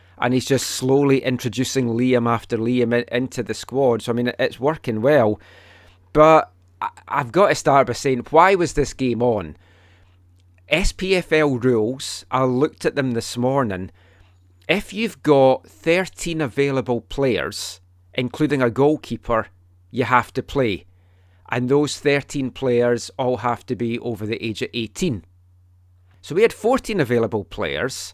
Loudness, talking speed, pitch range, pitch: -20 LUFS, 145 wpm, 95-140 Hz, 120 Hz